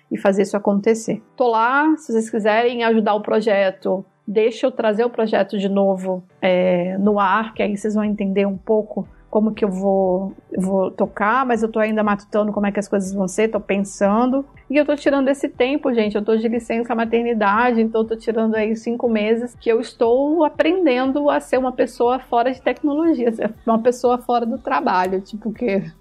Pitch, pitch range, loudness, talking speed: 225 Hz, 200-245 Hz, -19 LUFS, 200 wpm